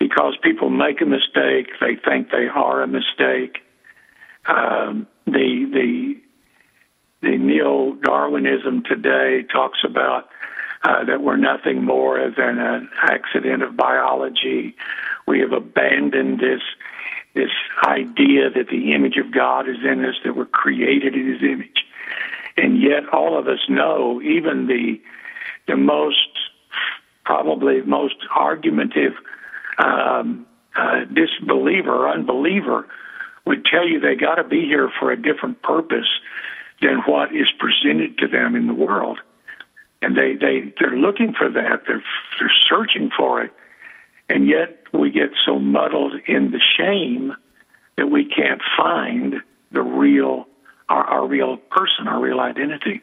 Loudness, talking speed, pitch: -18 LUFS, 140 wpm, 220 Hz